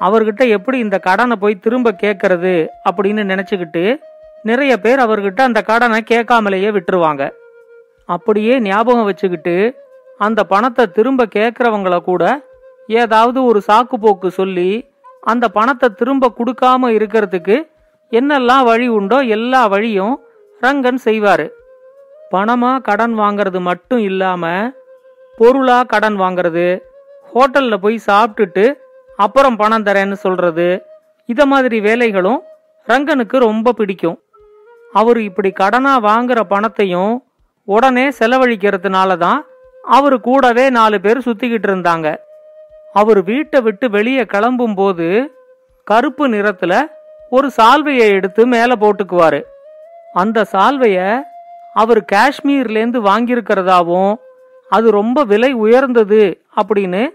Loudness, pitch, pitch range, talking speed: -13 LUFS, 230 Hz, 205-260 Hz, 105 wpm